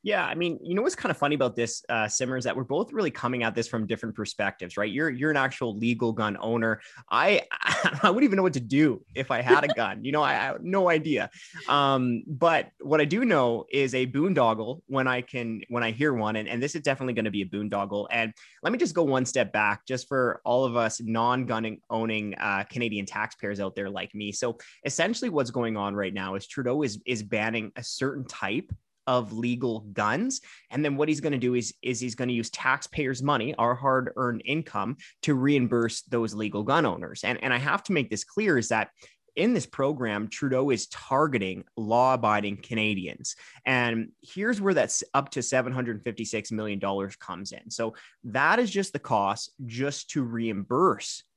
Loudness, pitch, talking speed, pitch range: -27 LUFS, 125 Hz, 215 wpm, 110-140 Hz